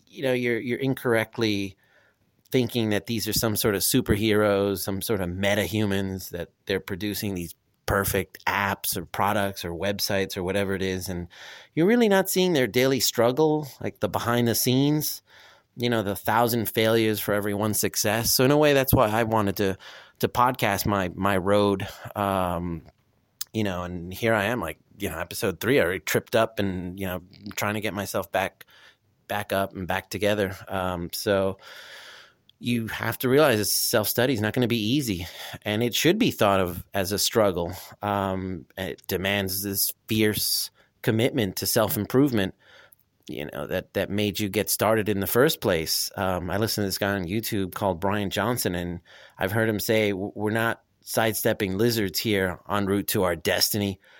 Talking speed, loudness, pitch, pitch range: 185 wpm, -25 LUFS, 105 Hz, 95-115 Hz